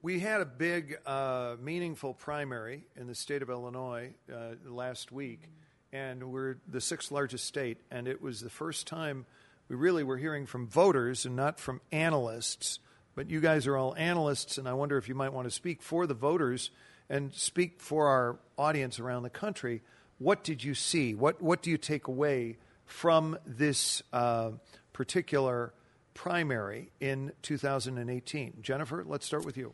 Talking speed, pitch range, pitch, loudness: 180 wpm, 125-155 Hz, 135 Hz, -33 LUFS